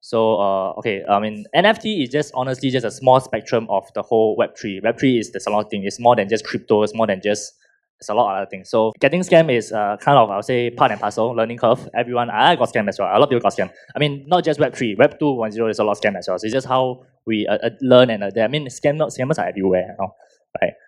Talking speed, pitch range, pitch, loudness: 290 wpm, 105-130 Hz, 115 Hz, -19 LUFS